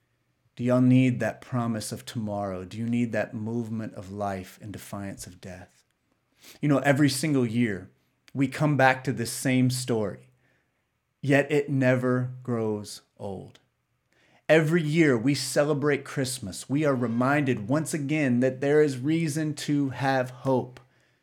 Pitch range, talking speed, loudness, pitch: 115-140 Hz, 145 wpm, -26 LUFS, 125 Hz